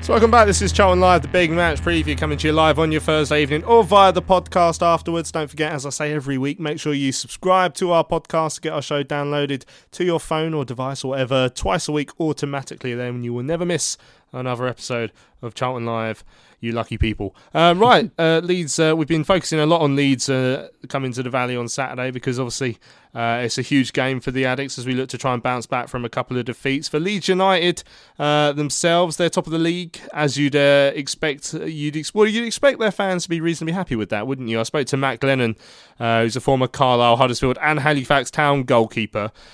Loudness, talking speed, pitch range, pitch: -19 LUFS, 230 wpm, 125-165 Hz, 145 Hz